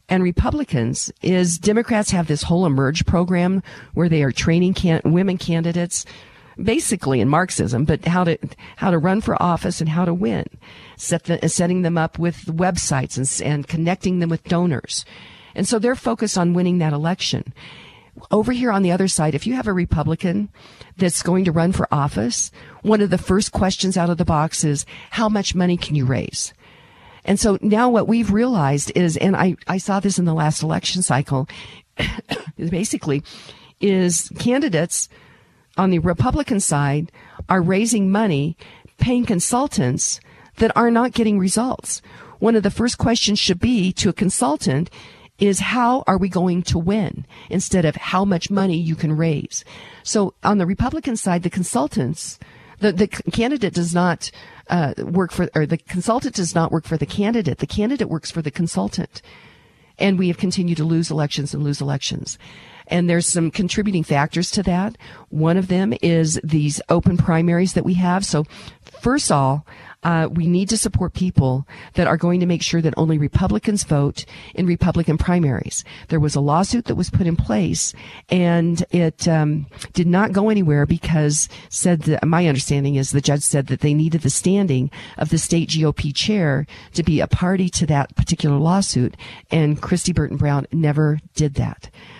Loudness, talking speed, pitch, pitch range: -19 LUFS, 180 wpm, 175 Hz, 155-195 Hz